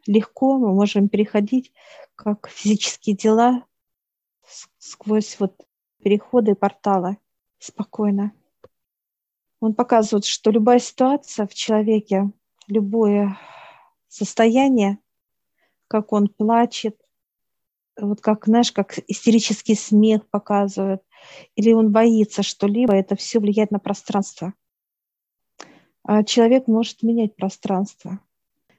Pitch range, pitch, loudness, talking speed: 205-230 Hz, 215 Hz, -19 LUFS, 95 wpm